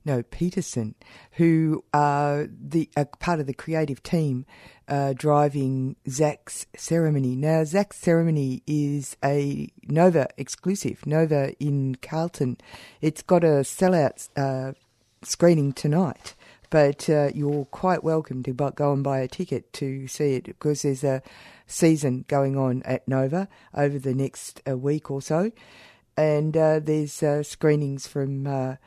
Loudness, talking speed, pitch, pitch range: -24 LUFS, 140 wpm, 145 Hz, 135-160 Hz